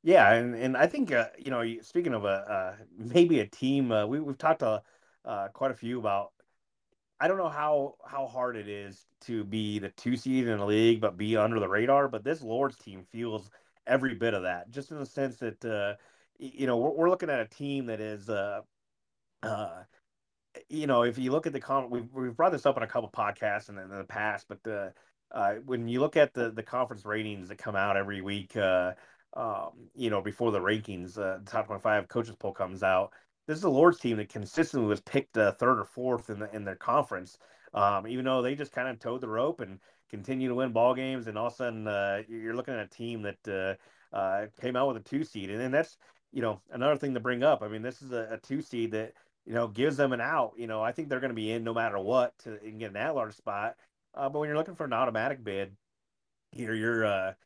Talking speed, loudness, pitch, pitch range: 245 wpm, -30 LUFS, 115 Hz, 105-130 Hz